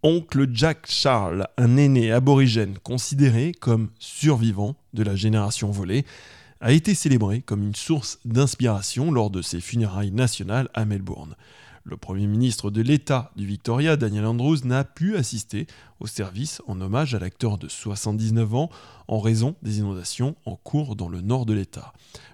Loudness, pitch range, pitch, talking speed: -23 LUFS, 105-135 Hz, 115 Hz, 160 wpm